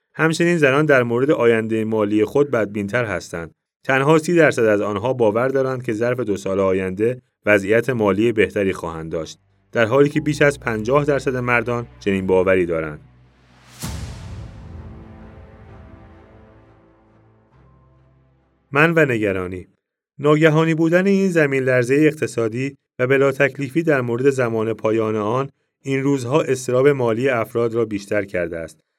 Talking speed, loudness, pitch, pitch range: 130 wpm, -18 LUFS, 110 Hz, 100-135 Hz